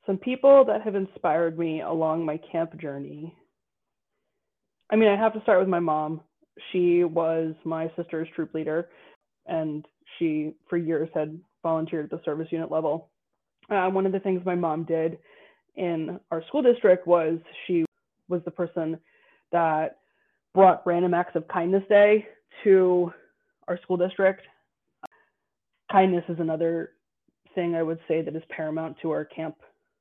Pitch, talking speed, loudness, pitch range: 170 Hz, 155 wpm, -25 LUFS, 160-185 Hz